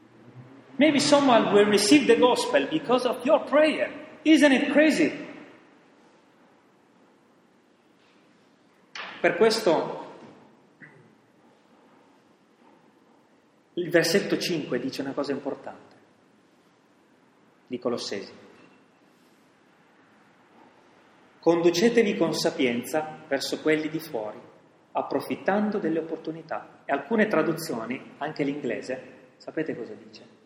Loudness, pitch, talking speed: -24 LUFS, 200 Hz, 85 wpm